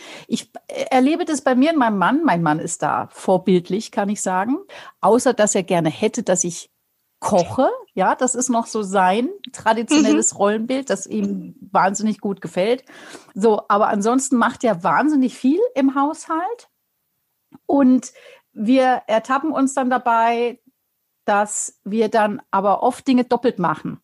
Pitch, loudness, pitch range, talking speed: 235 Hz, -19 LUFS, 205-270 Hz, 150 wpm